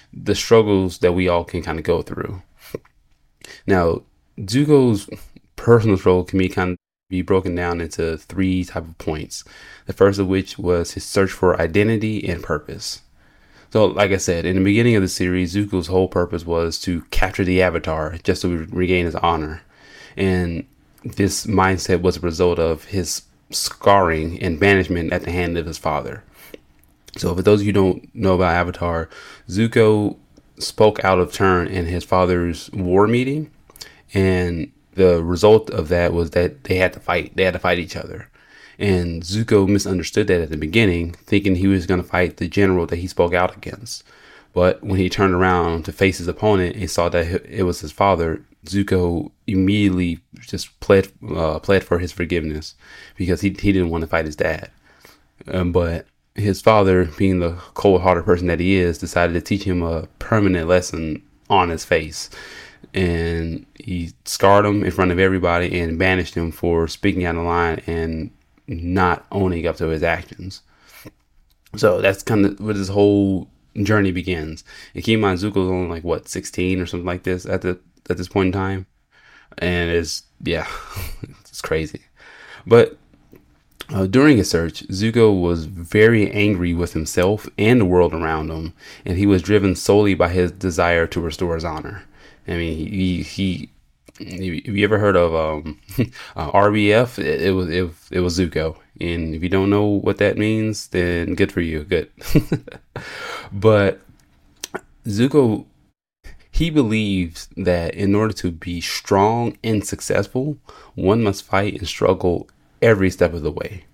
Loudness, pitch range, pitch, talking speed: -19 LUFS, 85-100 Hz, 90 Hz, 170 wpm